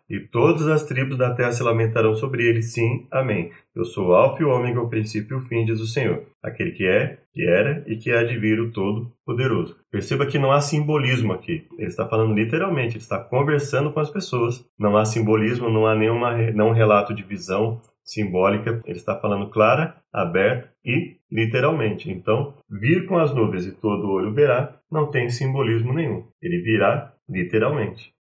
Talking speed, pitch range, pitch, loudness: 190 wpm, 110-140 Hz, 115 Hz, -22 LUFS